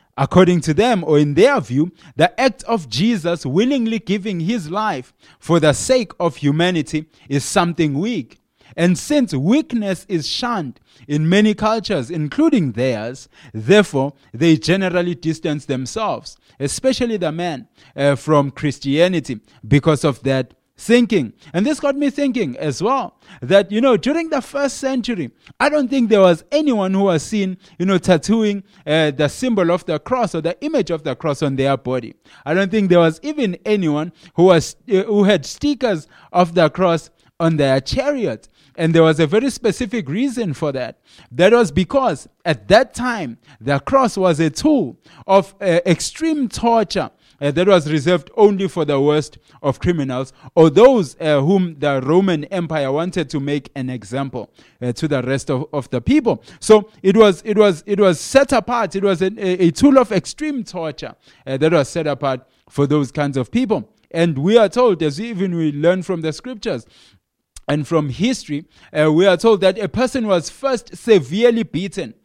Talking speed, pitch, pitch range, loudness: 180 wpm, 175 Hz, 150-215 Hz, -17 LUFS